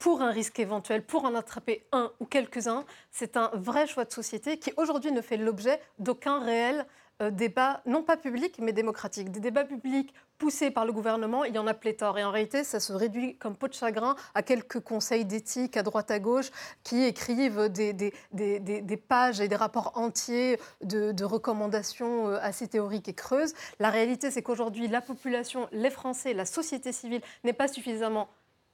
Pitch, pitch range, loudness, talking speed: 235 Hz, 220-260 Hz, -30 LUFS, 190 wpm